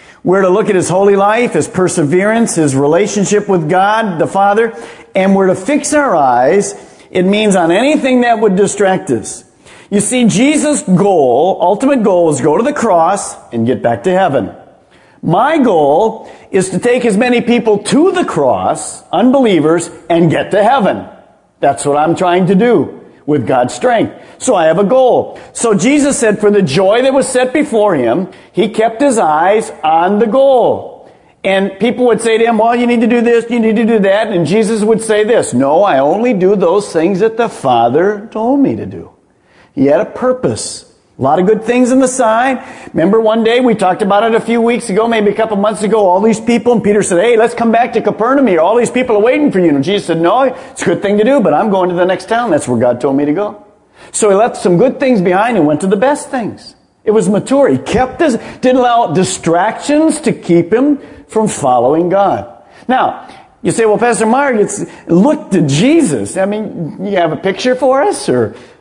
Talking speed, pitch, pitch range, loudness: 215 wpm, 215 Hz, 185-245 Hz, -11 LUFS